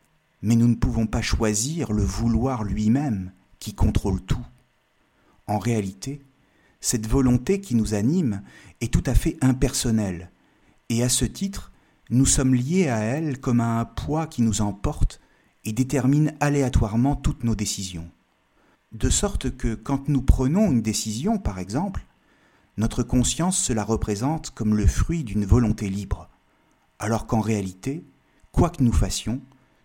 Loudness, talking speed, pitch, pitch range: -24 LUFS, 150 wpm, 115 Hz, 105-135 Hz